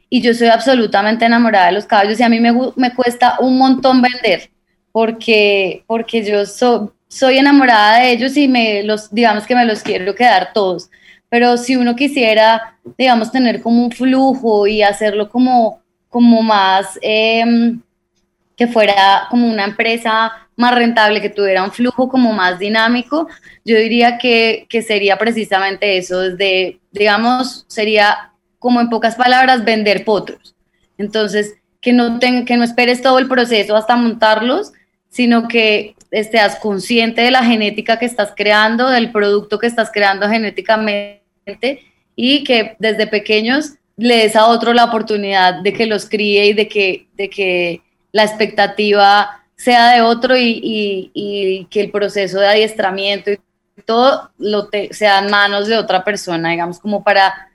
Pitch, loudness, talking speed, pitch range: 220 Hz, -13 LUFS, 160 wpm, 205-240 Hz